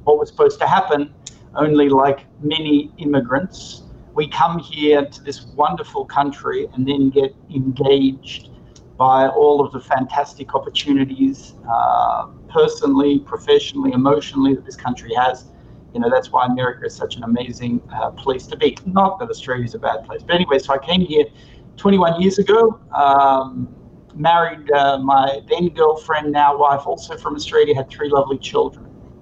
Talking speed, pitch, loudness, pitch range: 160 wpm, 145 Hz, -17 LUFS, 135-190 Hz